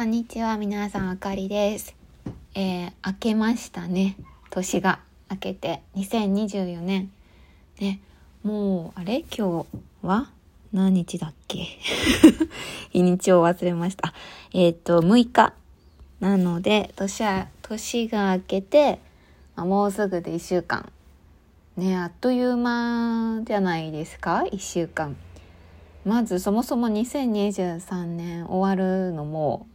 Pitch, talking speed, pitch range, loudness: 190 Hz, 230 characters per minute, 175-215 Hz, -24 LUFS